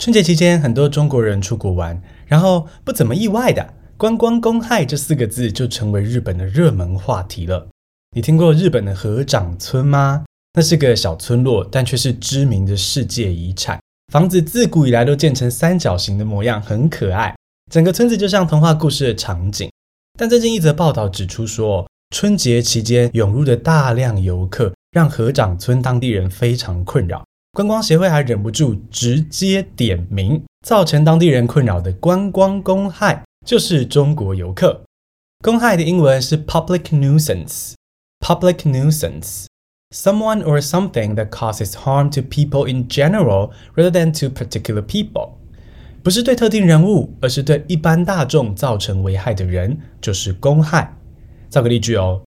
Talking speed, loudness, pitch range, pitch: 345 characters per minute, -16 LUFS, 105-165 Hz, 130 Hz